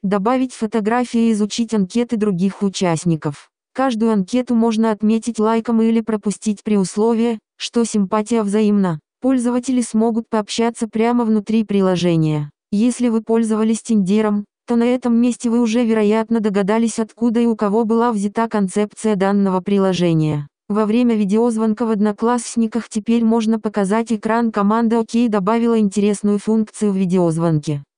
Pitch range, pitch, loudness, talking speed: 205-230 Hz, 220 Hz, -18 LUFS, 135 wpm